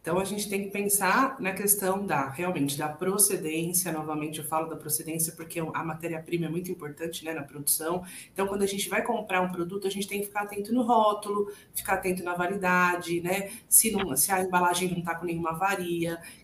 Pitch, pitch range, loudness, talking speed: 180 Hz, 165-200 Hz, -27 LUFS, 210 wpm